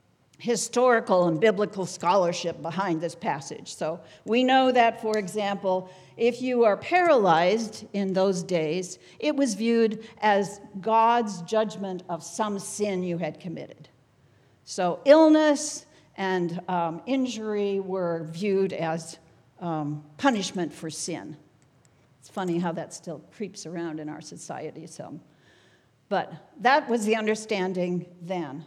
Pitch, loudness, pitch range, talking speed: 185 Hz, -25 LUFS, 165-220 Hz, 130 wpm